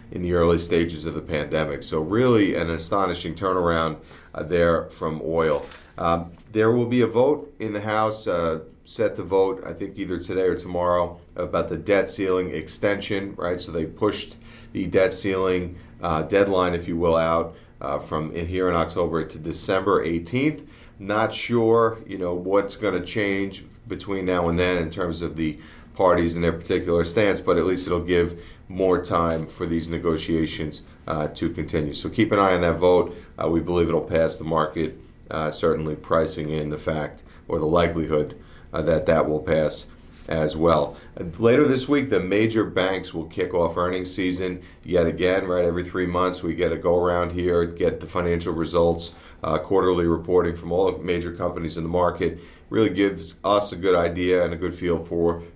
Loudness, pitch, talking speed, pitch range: -23 LUFS, 85 Hz, 190 wpm, 85-95 Hz